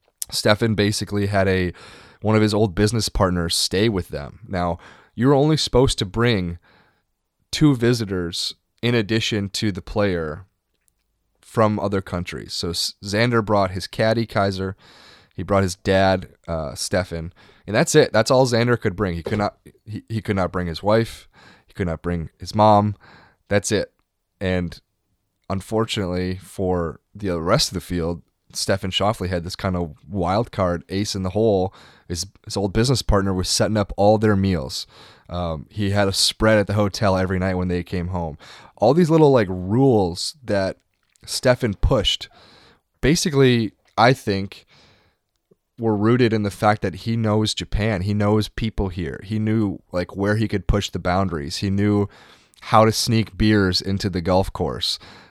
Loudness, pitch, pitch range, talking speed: -21 LUFS, 100 Hz, 90-110 Hz, 170 wpm